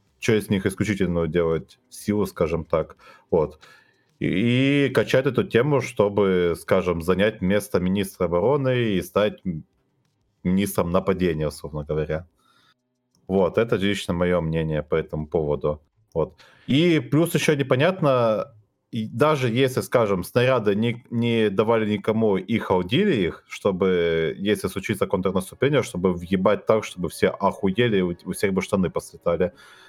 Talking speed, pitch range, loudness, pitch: 130 wpm, 90-120 Hz, -23 LUFS, 100 Hz